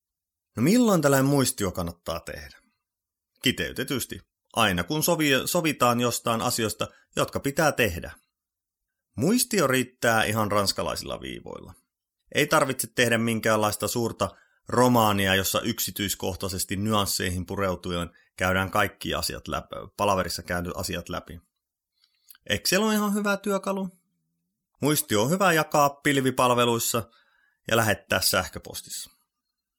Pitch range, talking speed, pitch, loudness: 95-150 Hz, 105 wpm, 115 Hz, -25 LUFS